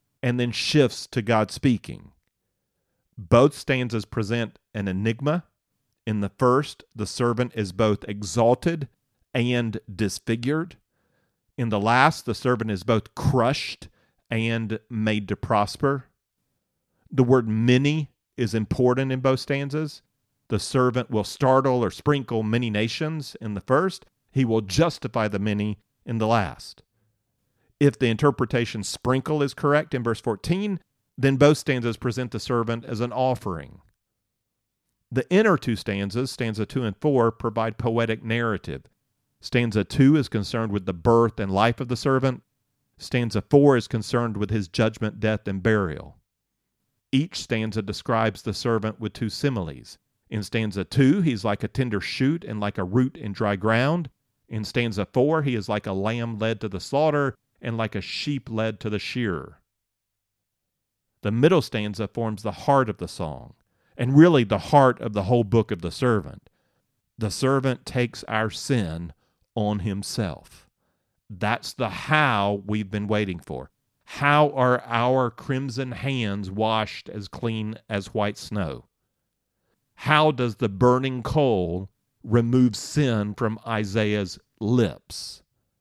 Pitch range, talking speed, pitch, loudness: 105-130 Hz, 145 wpm, 115 Hz, -24 LUFS